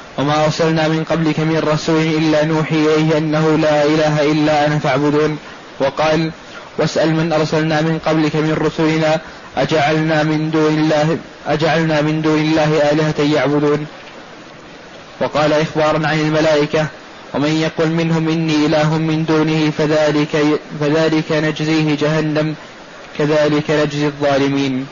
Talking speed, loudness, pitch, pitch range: 125 wpm, -15 LUFS, 155 Hz, 150-155 Hz